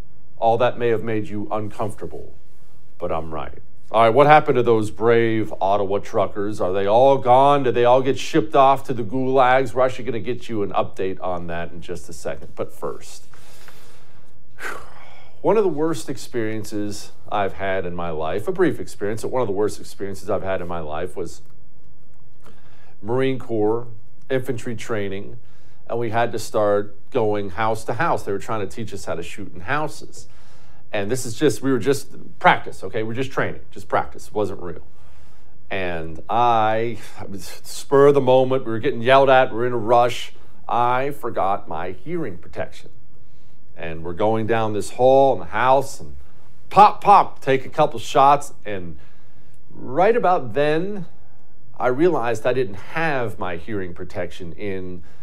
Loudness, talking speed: -21 LUFS, 180 wpm